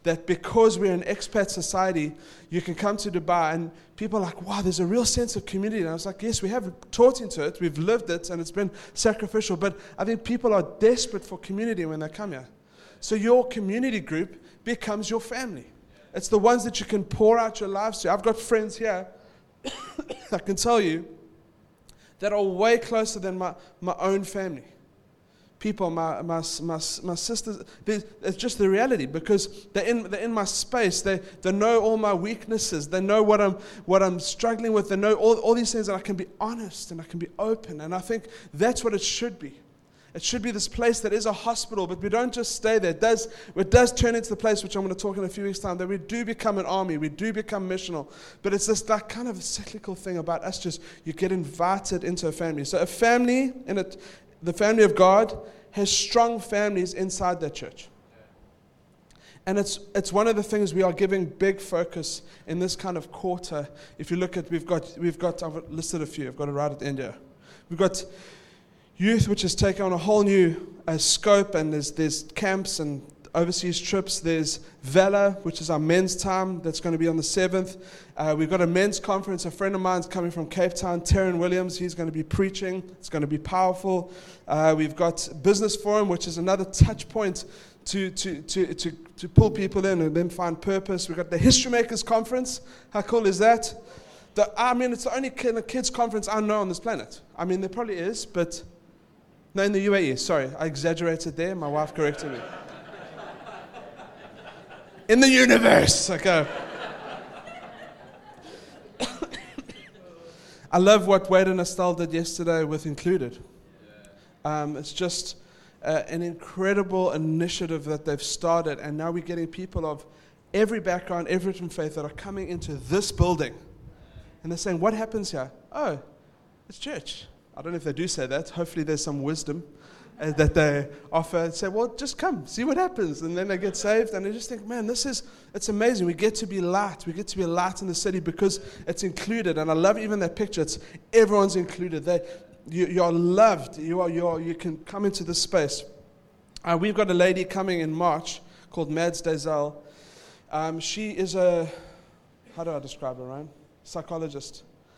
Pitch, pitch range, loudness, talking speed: 185 Hz, 170-210 Hz, -25 LUFS, 200 wpm